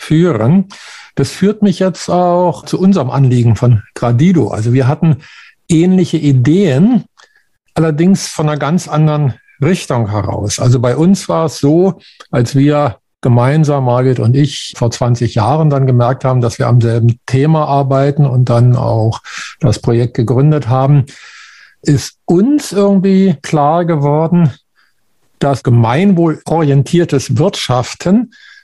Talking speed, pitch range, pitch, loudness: 130 wpm, 125-170 Hz, 145 Hz, -12 LUFS